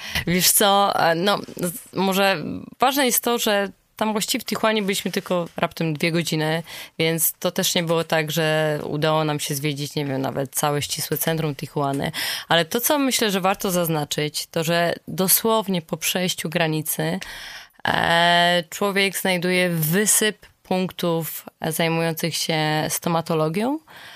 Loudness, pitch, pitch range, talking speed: -21 LUFS, 170 Hz, 160-200 Hz, 135 wpm